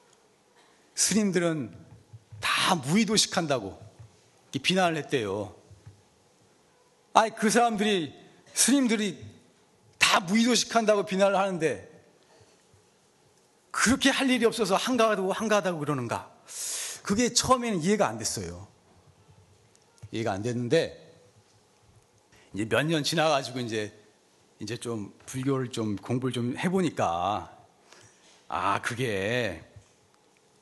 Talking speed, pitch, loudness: 225 characters per minute, 165 Hz, -26 LUFS